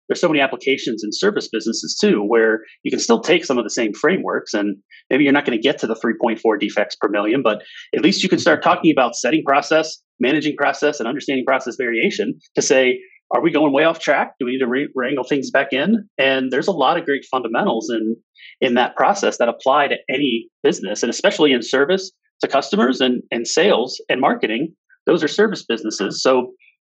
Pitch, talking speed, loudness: 145 Hz, 215 wpm, -18 LUFS